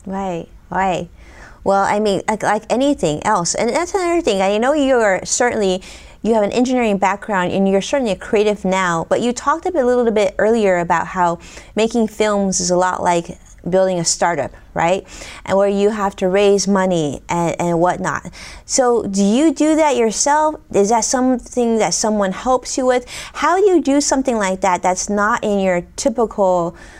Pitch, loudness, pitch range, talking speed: 205 Hz, -17 LUFS, 185-245 Hz, 190 wpm